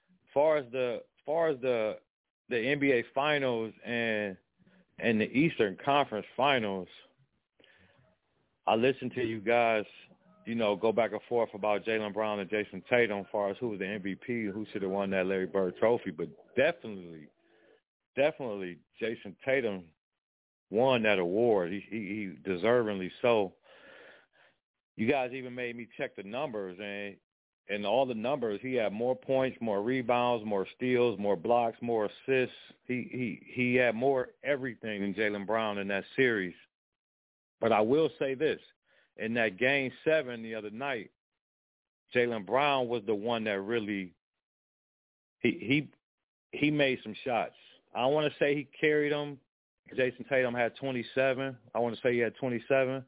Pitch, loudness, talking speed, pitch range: 115 Hz, -31 LUFS, 160 wpm, 105-130 Hz